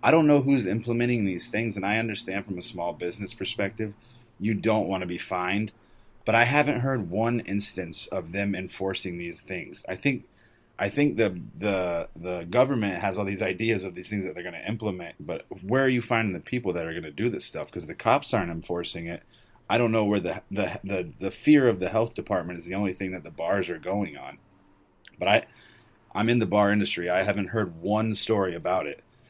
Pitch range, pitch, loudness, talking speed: 95-115 Hz, 105 Hz, -27 LUFS, 225 wpm